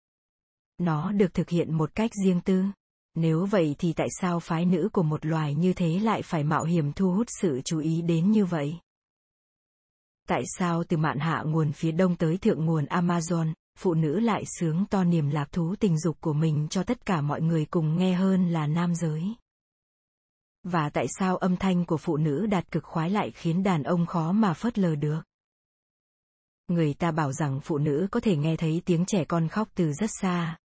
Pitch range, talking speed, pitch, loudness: 160-190 Hz, 205 wpm, 170 Hz, -26 LUFS